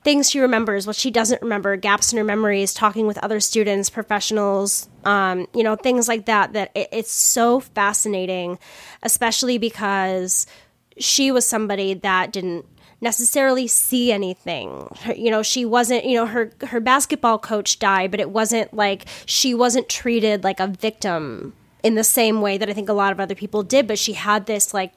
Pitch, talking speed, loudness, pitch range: 215 Hz, 185 wpm, -19 LUFS, 200-235 Hz